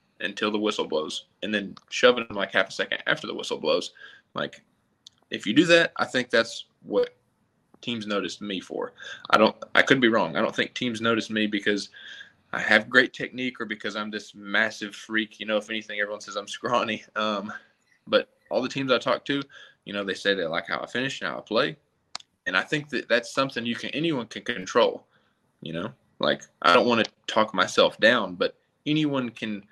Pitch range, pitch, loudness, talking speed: 105-155 Hz, 115 Hz, -25 LUFS, 215 wpm